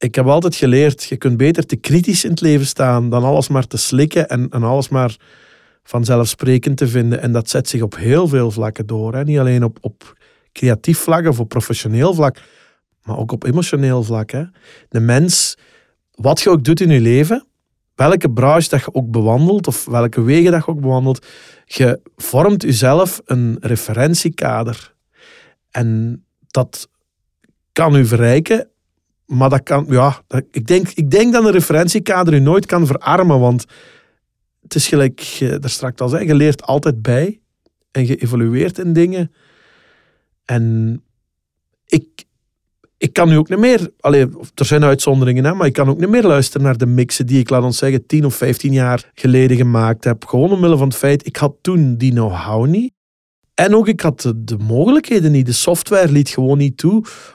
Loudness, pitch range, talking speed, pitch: -14 LUFS, 125-160 Hz, 180 wpm, 135 Hz